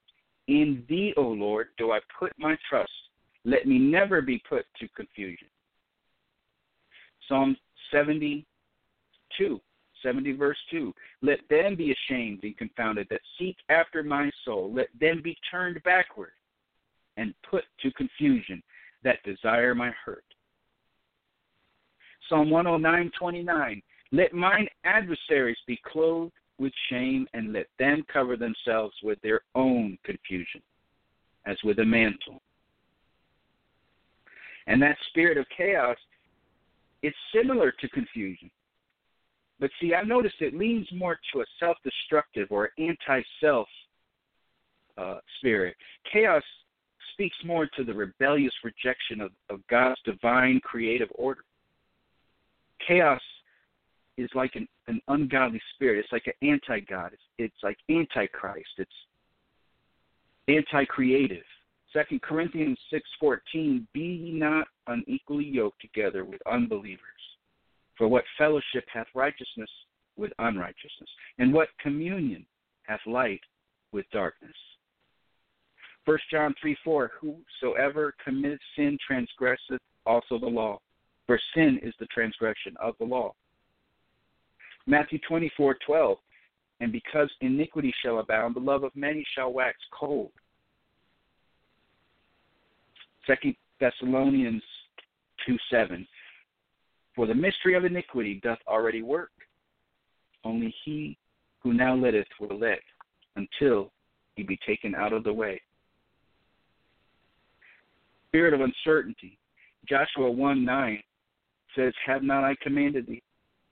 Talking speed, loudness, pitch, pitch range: 115 wpm, -27 LUFS, 140 Hz, 120-170 Hz